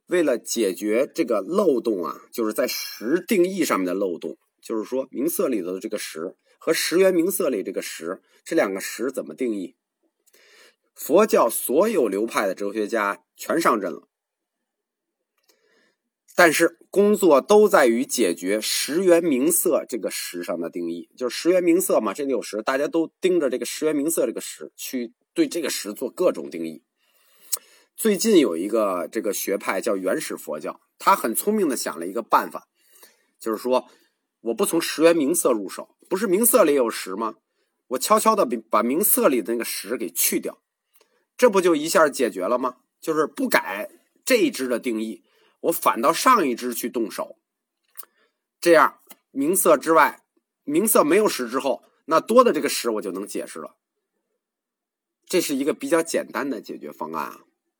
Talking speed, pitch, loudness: 255 characters per minute, 180 Hz, -22 LUFS